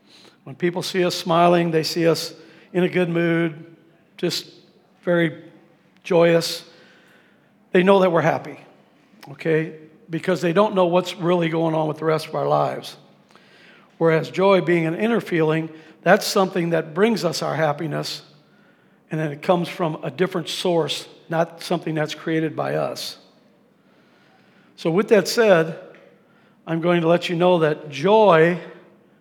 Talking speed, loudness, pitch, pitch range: 150 wpm, -20 LUFS, 170 Hz, 160-185 Hz